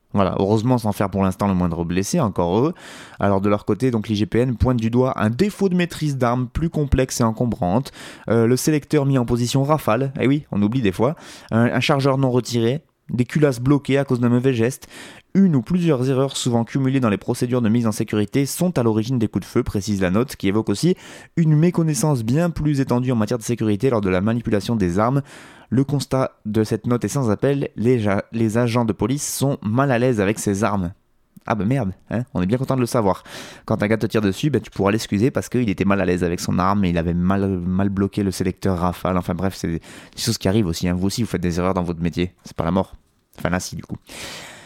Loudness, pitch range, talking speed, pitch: -20 LUFS, 100-130 Hz, 245 wpm, 115 Hz